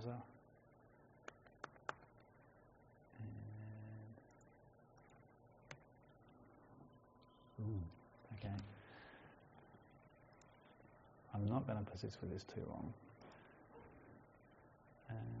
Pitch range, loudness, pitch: 110-125 Hz, -51 LUFS, 120 Hz